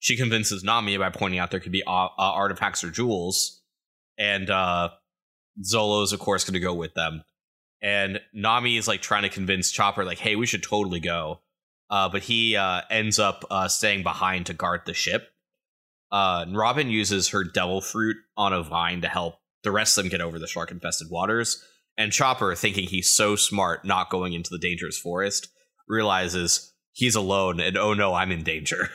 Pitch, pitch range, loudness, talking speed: 100 Hz, 90-105 Hz, -24 LUFS, 190 wpm